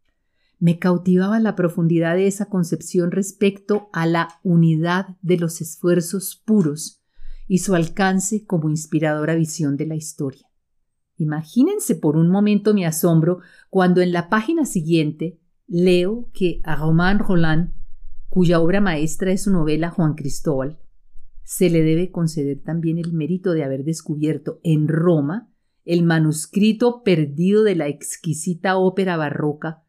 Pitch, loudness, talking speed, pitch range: 170 Hz, -20 LUFS, 135 wpm, 155-190 Hz